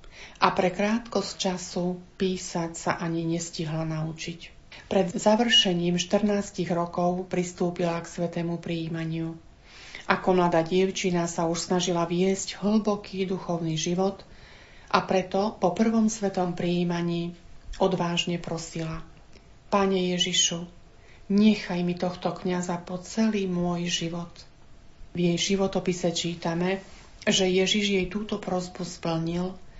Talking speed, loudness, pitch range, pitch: 110 wpm, -26 LUFS, 170-190 Hz, 180 Hz